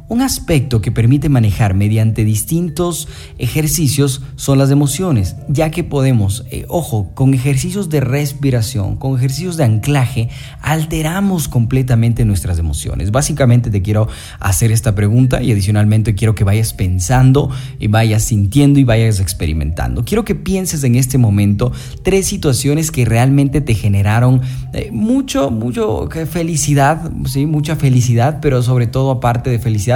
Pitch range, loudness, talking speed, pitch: 110-145 Hz, -14 LUFS, 140 wpm, 130 Hz